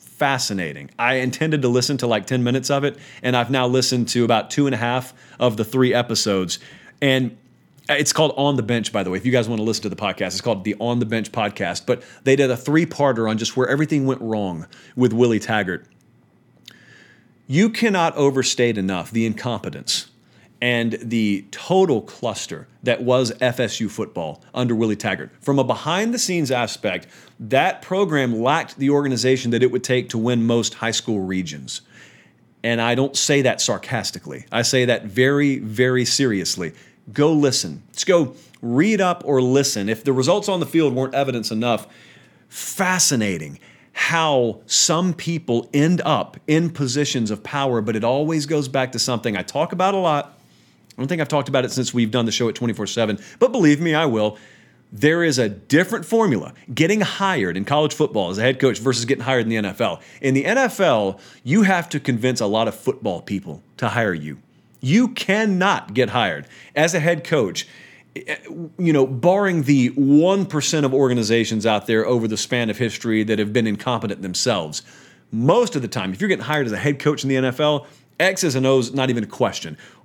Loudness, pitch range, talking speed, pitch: -20 LUFS, 115-145 Hz, 195 wpm, 130 Hz